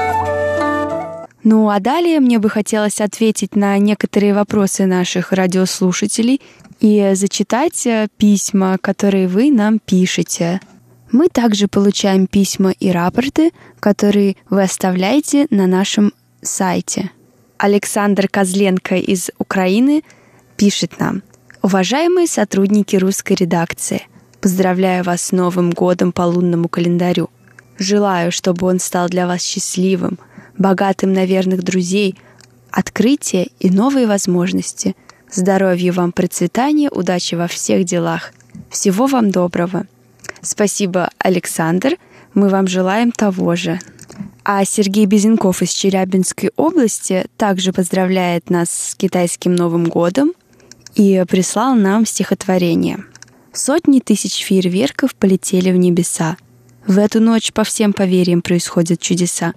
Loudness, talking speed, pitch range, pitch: -15 LUFS, 110 wpm, 180-210 Hz, 195 Hz